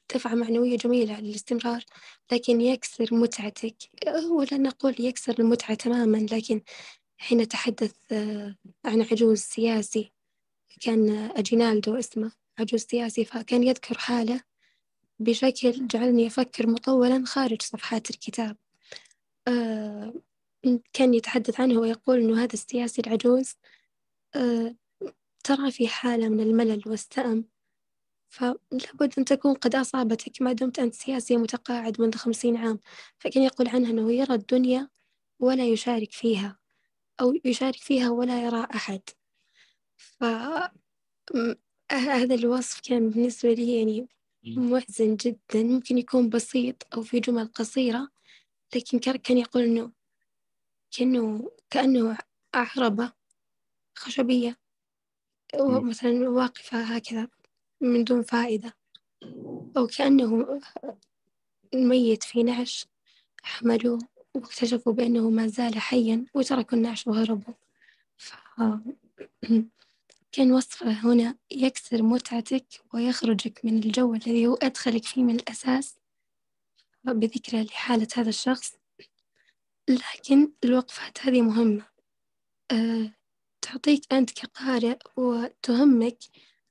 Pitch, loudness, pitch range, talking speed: 240 Hz, -26 LUFS, 230-255 Hz, 100 wpm